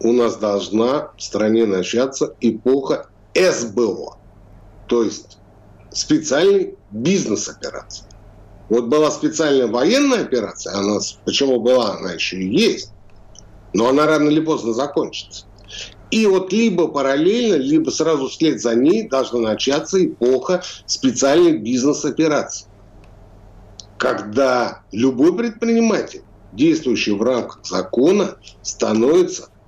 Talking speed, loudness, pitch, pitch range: 110 wpm, -18 LUFS, 120 Hz, 105-160 Hz